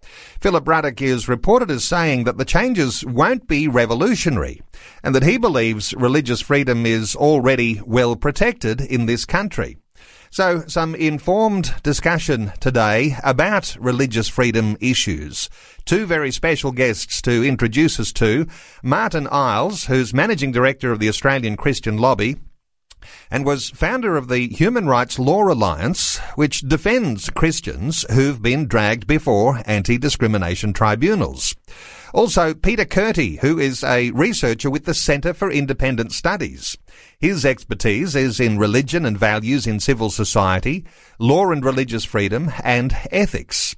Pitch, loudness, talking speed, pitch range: 135 Hz, -18 LUFS, 135 wpm, 115-155 Hz